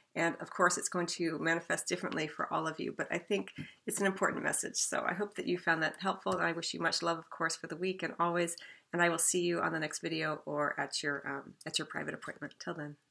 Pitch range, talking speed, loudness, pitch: 155-180 Hz, 270 wpm, -34 LUFS, 165 Hz